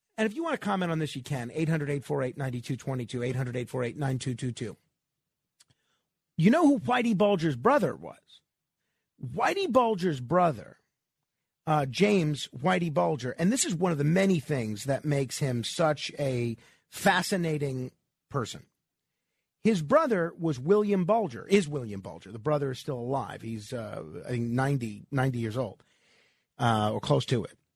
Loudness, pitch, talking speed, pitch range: -28 LUFS, 145 Hz, 155 wpm, 125-180 Hz